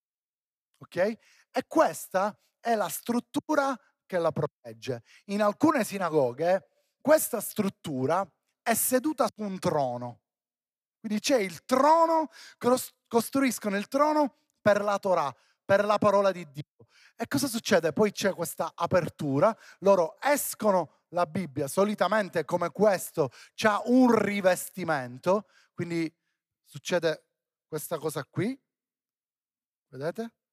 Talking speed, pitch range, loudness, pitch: 110 wpm, 170-235 Hz, -27 LUFS, 200 Hz